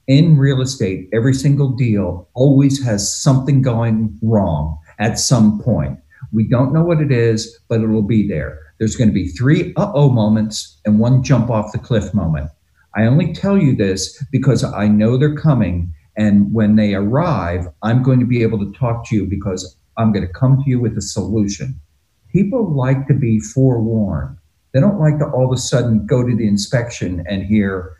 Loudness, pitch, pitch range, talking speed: -16 LUFS, 110 Hz, 100-130 Hz, 195 wpm